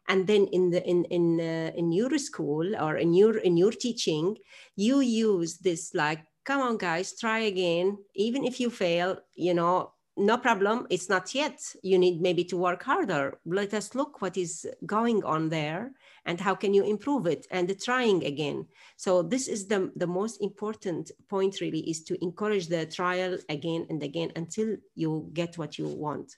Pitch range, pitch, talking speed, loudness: 170-215 Hz, 185 Hz, 190 wpm, -28 LUFS